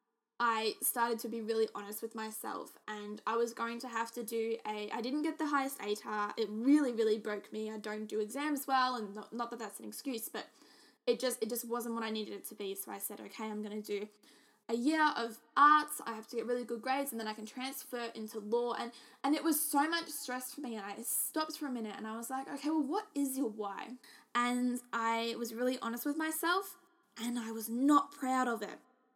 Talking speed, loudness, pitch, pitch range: 240 wpm, -35 LUFS, 235 Hz, 220-265 Hz